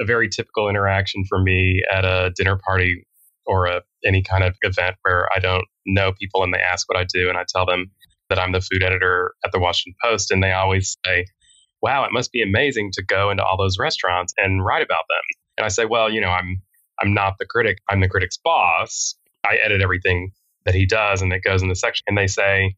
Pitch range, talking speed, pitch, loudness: 90-100 Hz, 235 wpm, 95 Hz, -19 LUFS